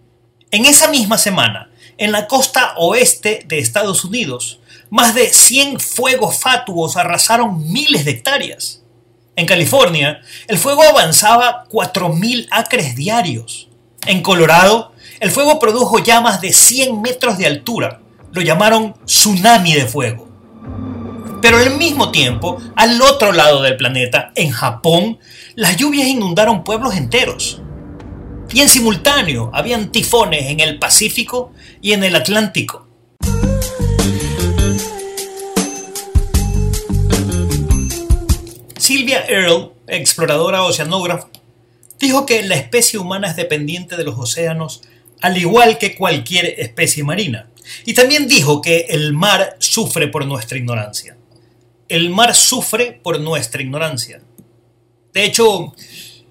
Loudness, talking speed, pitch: -12 LUFS, 115 wpm, 170 Hz